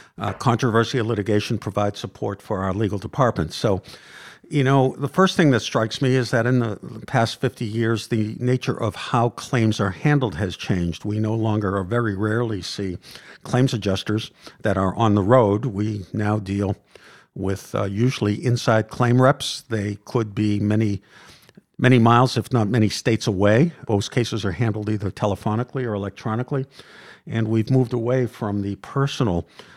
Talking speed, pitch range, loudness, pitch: 165 wpm, 105-125 Hz, -22 LUFS, 110 Hz